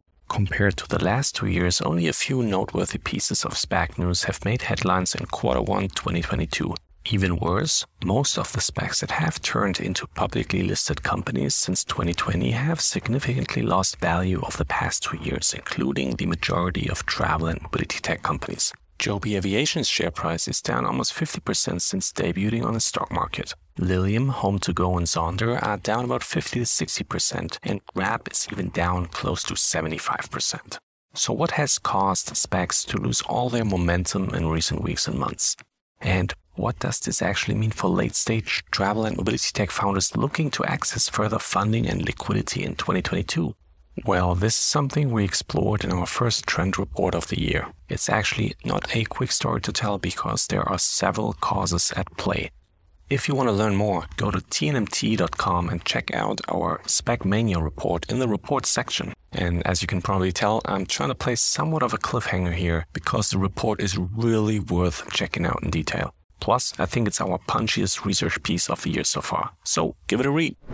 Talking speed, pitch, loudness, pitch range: 185 wpm, 95 Hz, -24 LUFS, 85-105 Hz